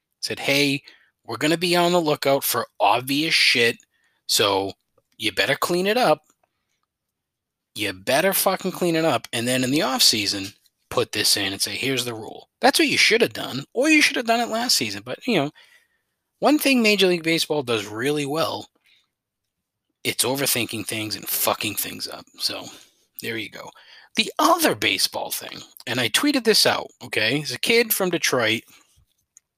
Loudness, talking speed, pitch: -21 LUFS, 180 wpm, 150 Hz